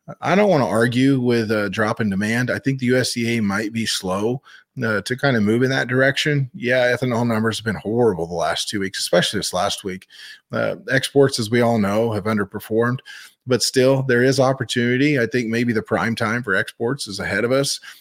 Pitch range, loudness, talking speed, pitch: 110-130 Hz, -20 LUFS, 215 wpm, 120 Hz